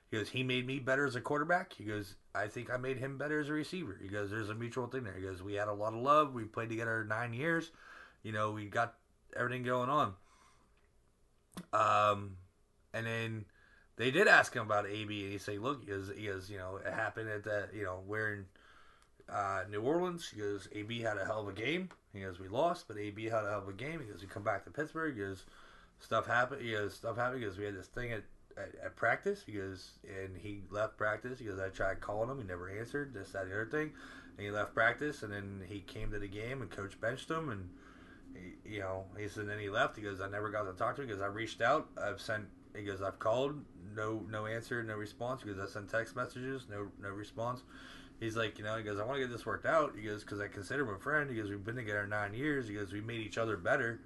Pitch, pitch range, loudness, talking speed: 105 Hz, 100-125 Hz, -37 LUFS, 255 wpm